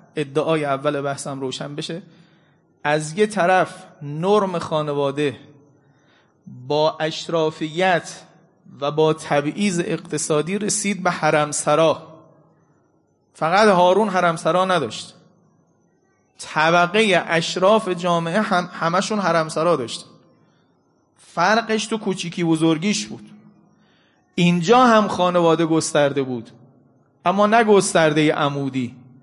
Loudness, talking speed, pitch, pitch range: -19 LUFS, 95 wpm, 170 Hz, 150-185 Hz